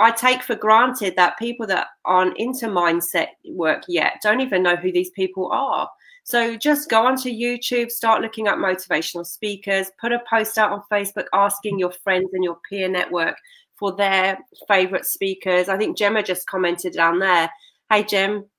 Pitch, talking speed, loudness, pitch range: 200 Hz, 180 wpm, -20 LUFS, 185-225 Hz